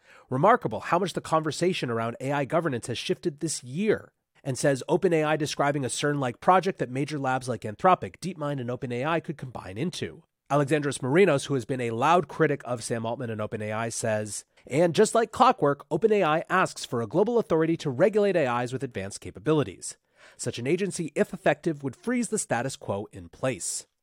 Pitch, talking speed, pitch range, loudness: 145 Hz, 180 wpm, 125-175 Hz, -26 LUFS